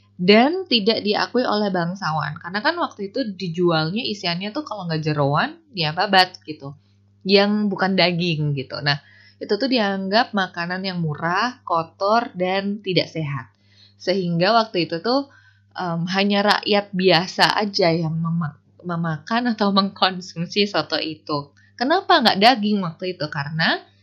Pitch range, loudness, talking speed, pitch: 155-205 Hz, -20 LUFS, 135 wpm, 180 Hz